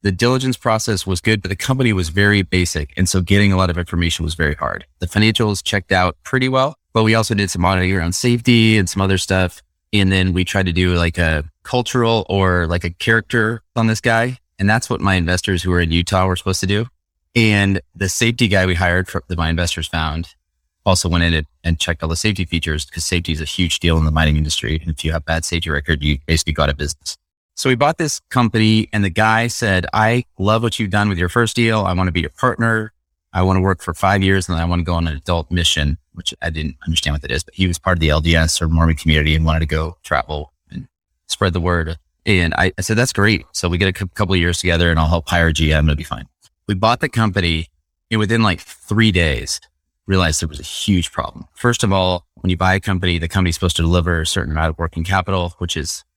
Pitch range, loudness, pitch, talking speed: 80-105 Hz, -17 LUFS, 90 Hz, 255 wpm